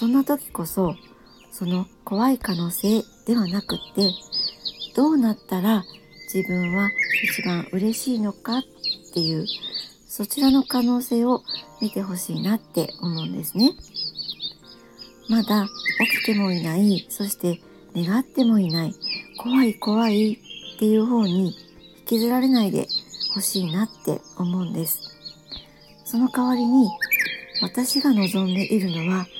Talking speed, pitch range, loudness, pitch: 255 characters per minute, 180-235 Hz, -23 LUFS, 205 Hz